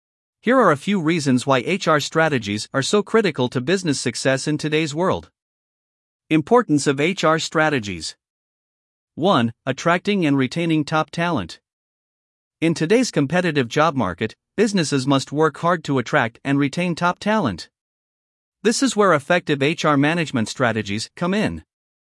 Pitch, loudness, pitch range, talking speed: 155 Hz, -20 LUFS, 135-175 Hz, 140 wpm